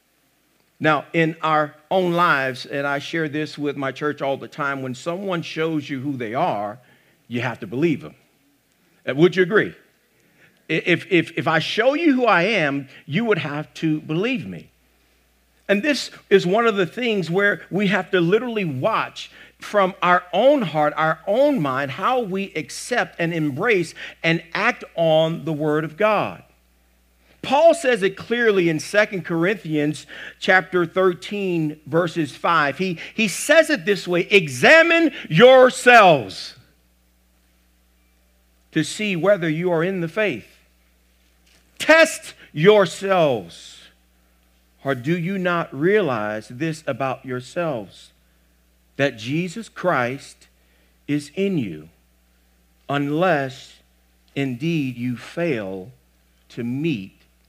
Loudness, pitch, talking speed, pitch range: -20 LUFS, 155 Hz, 135 wpm, 115-190 Hz